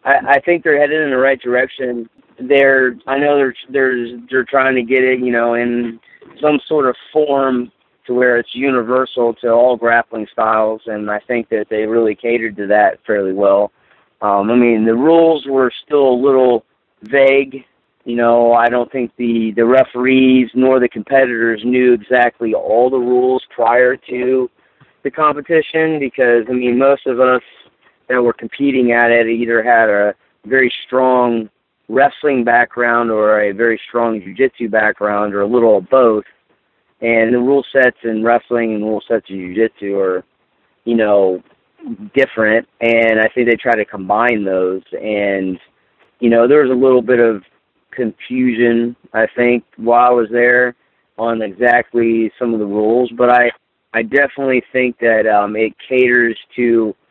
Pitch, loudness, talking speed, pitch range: 120 Hz, -14 LUFS, 170 wpm, 115-130 Hz